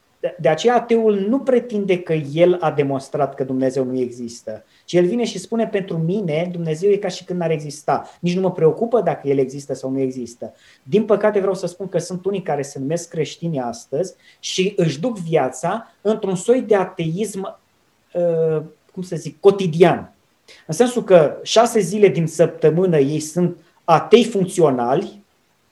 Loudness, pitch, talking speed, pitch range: -19 LUFS, 175 Hz, 170 wpm, 155-200 Hz